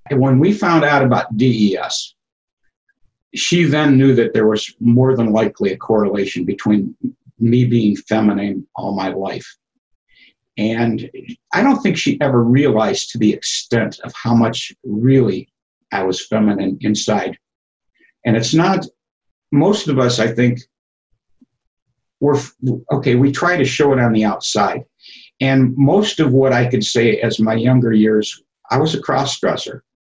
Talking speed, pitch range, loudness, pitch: 155 wpm, 110-140 Hz, -16 LUFS, 125 Hz